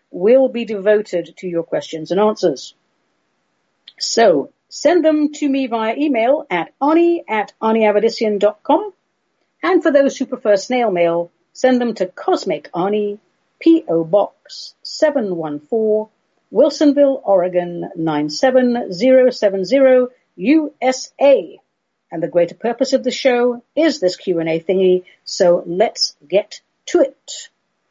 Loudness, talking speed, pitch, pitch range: -16 LUFS, 115 wpm, 225 Hz, 185-275 Hz